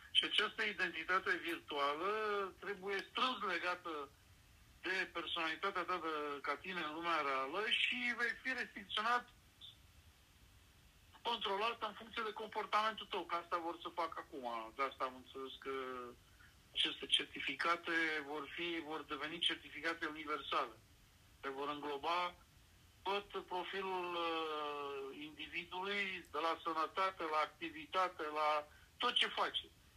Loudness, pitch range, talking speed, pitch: -40 LUFS, 140-185 Hz, 120 wpm, 165 Hz